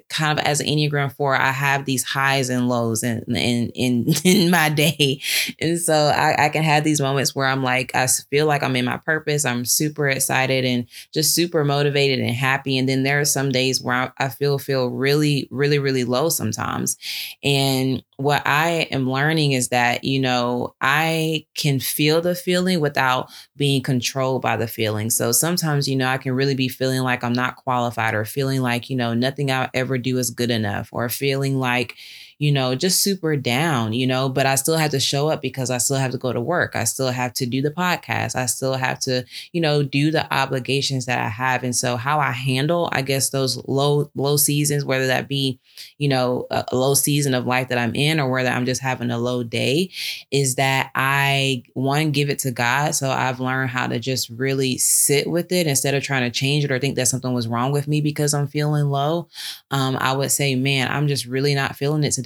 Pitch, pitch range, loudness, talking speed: 135 Hz, 125-145 Hz, -20 LUFS, 220 wpm